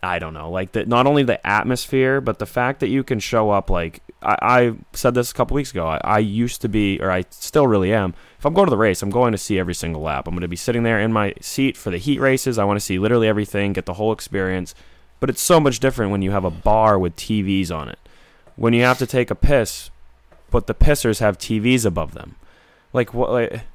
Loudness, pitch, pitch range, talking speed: -19 LUFS, 105 Hz, 90-125 Hz, 260 wpm